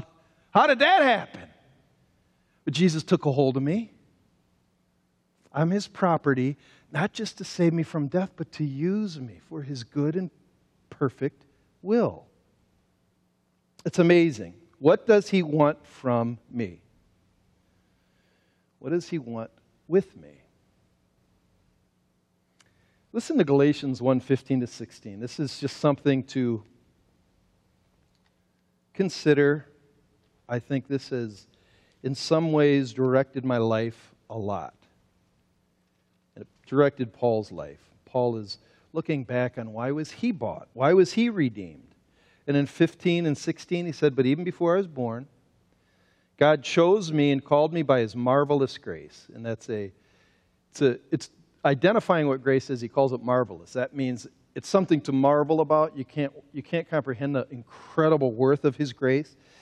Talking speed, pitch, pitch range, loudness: 145 wpm, 140 Hz, 120-160 Hz, -25 LUFS